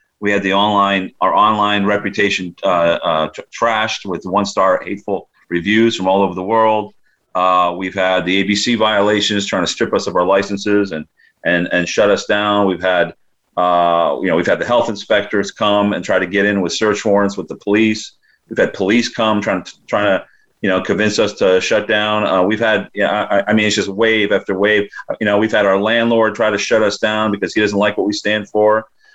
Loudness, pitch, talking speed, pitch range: -15 LUFS, 105 Hz, 220 wpm, 95-105 Hz